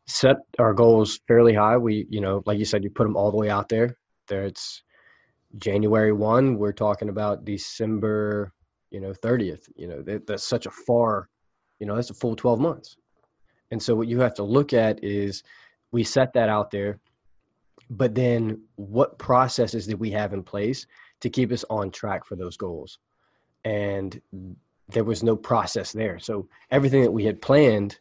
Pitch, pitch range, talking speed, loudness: 110 Hz, 100-115 Hz, 185 wpm, -23 LUFS